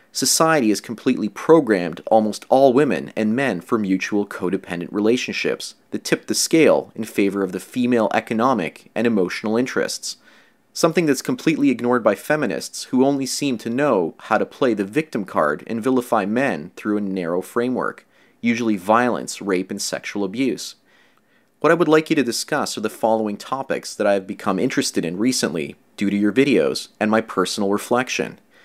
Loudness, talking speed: -20 LUFS, 170 wpm